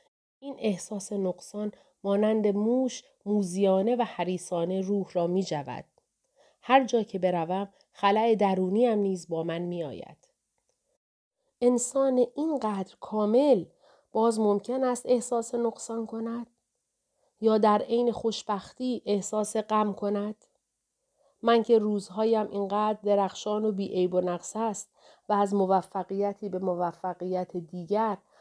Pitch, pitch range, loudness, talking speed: 210 Hz, 190-235 Hz, -28 LUFS, 120 wpm